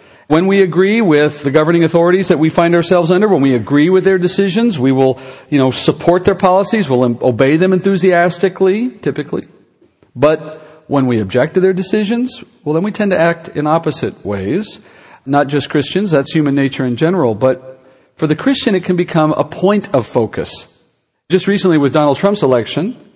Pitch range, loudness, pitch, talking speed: 145-190 Hz, -13 LUFS, 165 Hz, 185 wpm